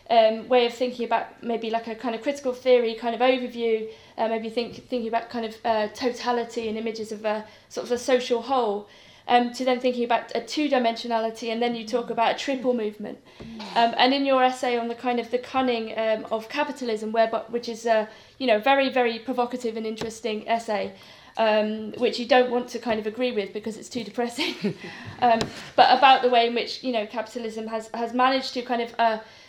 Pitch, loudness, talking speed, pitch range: 235 Hz, -24 LUFS, 220 wpm, 225-250 Hz